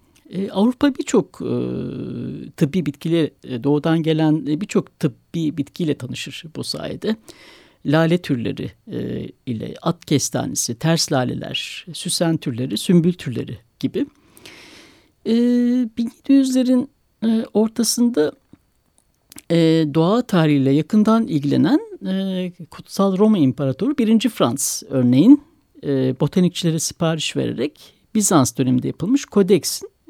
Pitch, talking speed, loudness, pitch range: 165 Hz, 105 wpm, -19 LUFS, 145-225 Hz